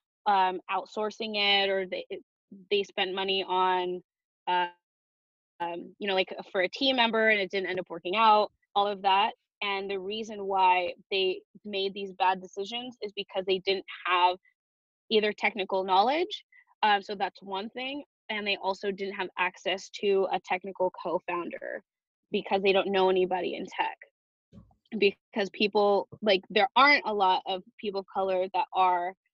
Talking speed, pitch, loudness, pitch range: 165 wpm, 195 Hz, -28 LUFS, 185-210 Hz